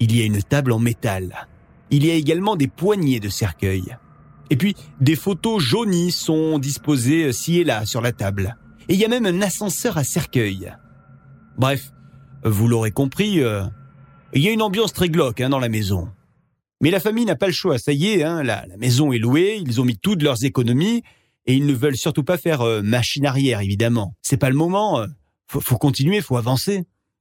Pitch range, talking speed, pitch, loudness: 120-170 Hz, 210 wpm, 135 Hz, -20 LUFS